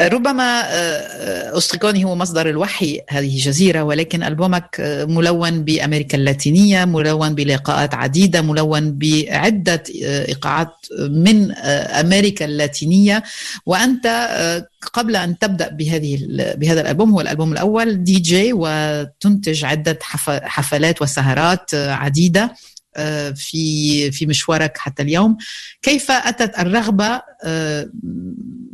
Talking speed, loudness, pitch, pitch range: 95 wpm, -16 LUFS, 165 Hz, 150-200 Hz